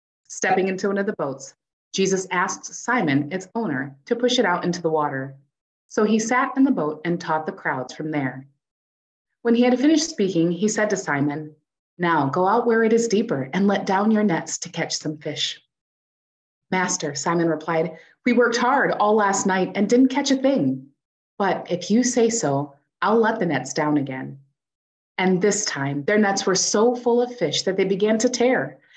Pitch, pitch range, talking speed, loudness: 185 Hz, 150-220 Hz, 195 wpm, -21 LUFS